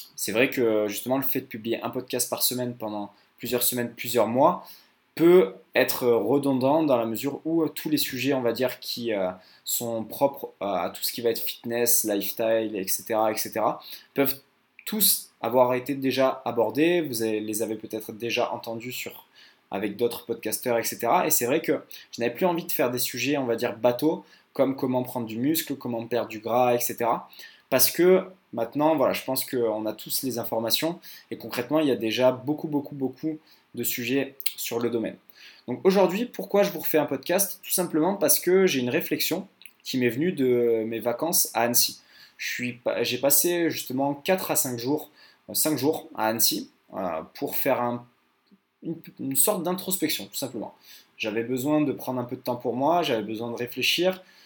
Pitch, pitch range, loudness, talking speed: 125 Hz, 115-155 Hz, -25 LUFS, 190 wpm